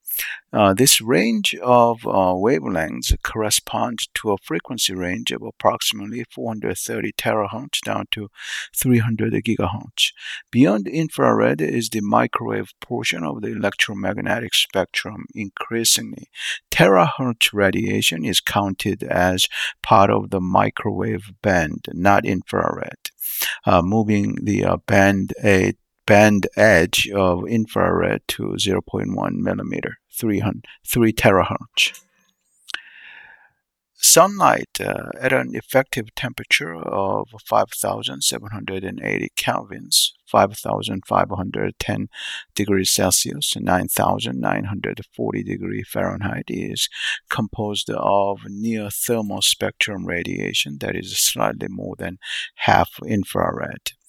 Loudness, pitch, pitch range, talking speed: -20 LUFS, 100 Hz, 95-110 Hz, 95 wpm